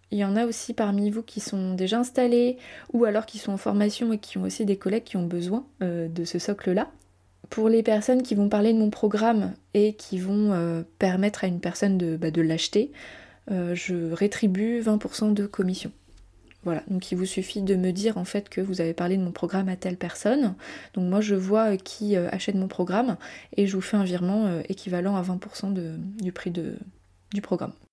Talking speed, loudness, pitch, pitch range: 210 wpm, -26 LUFS, 195 Hz, 180-215 Hz